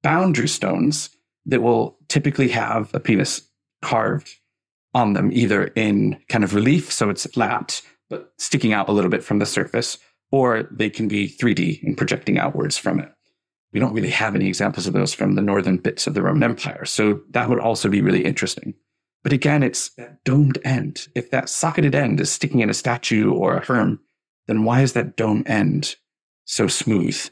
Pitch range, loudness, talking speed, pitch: 110-140 Hz, -20 LUFS, 190 wpm, 120 Hz